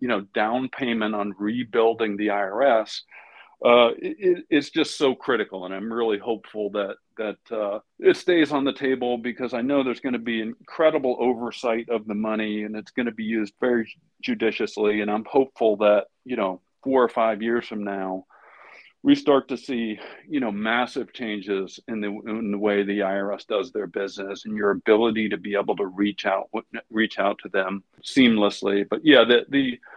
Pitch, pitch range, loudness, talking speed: 115 Hz, 105-125 Hz, -24 LUFS, 185 wpm